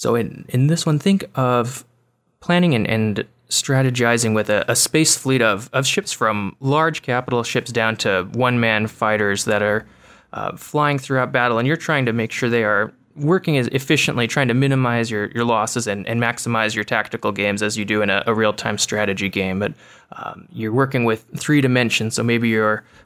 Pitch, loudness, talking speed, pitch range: 120 Hz, -19 LUFS, 200 wpm, 110-135 Hz